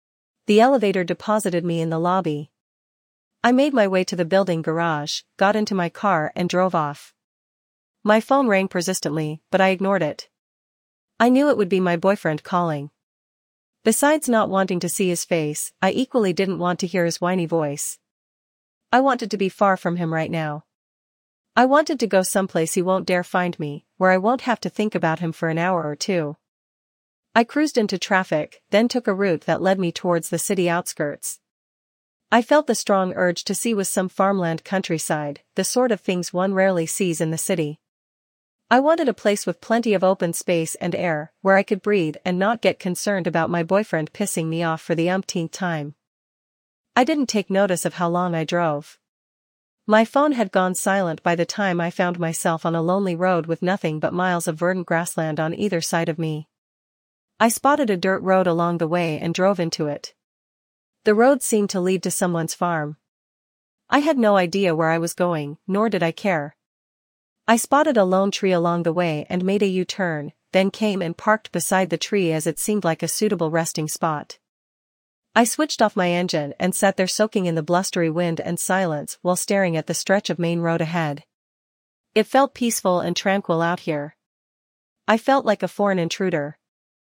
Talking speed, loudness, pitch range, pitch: 195 wpm, -21 LUFS, 165-200 Hz, 180 Hz